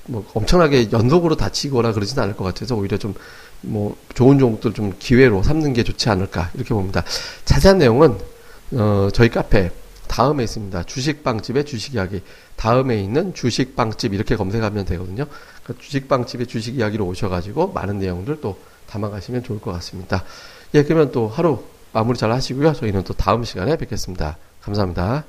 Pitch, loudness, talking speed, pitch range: 115 Hz, -19 LUFS, 390 characters per minute, 100-130 Hz